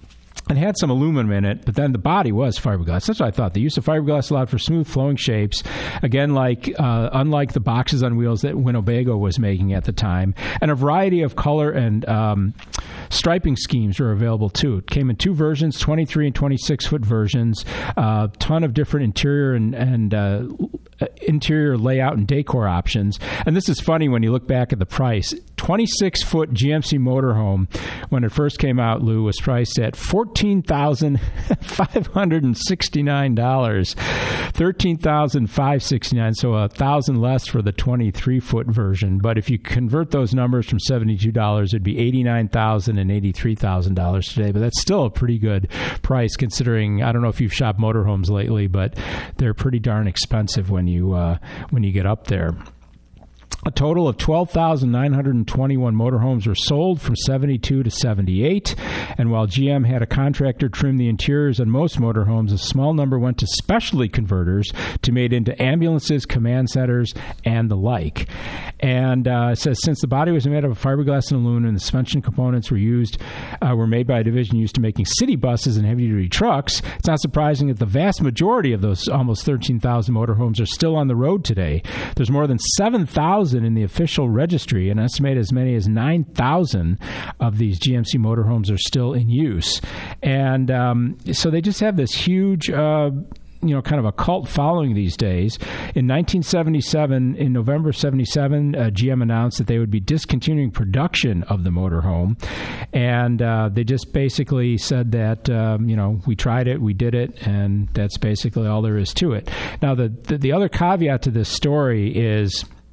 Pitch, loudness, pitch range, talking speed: 125 Hz, -19 LUFS, 110-140 Hz, 180 wpm